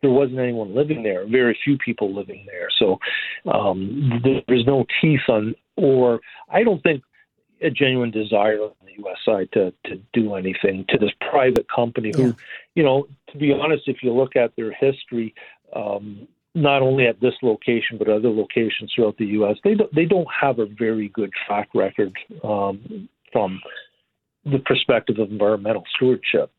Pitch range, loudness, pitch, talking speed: 105-135 Hz, -20 LUFS, 120 Hz, 170 wpm